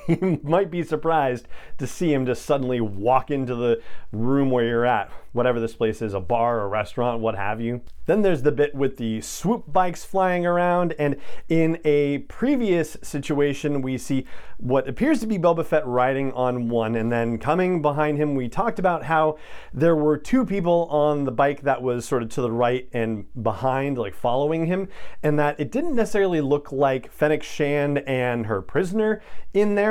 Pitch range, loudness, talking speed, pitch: 125-170 Hz, -23 LUFS, 190 wpm, 145 Hz